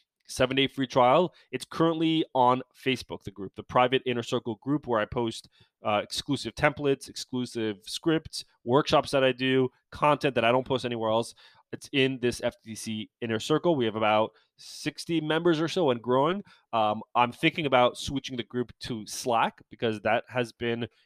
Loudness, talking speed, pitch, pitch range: -27 LUFS, 175 wpm, 125 Hz, 115-140 Hz